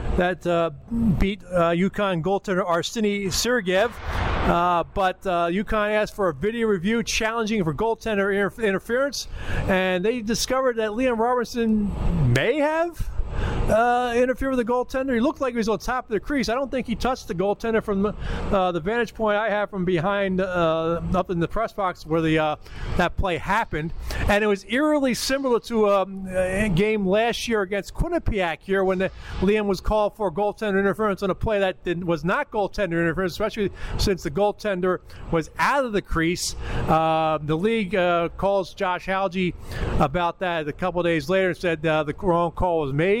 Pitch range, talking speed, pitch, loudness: 175-220 Hz, 185 wpm, 195 Hz, -23 LUFS